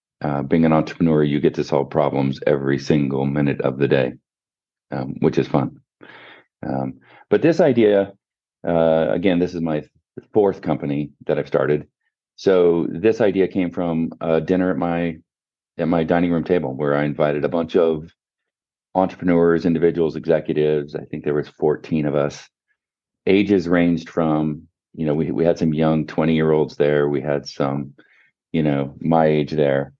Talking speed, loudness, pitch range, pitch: 170 wpm, -20 LUFS, 75-85 Hz, 80 Hz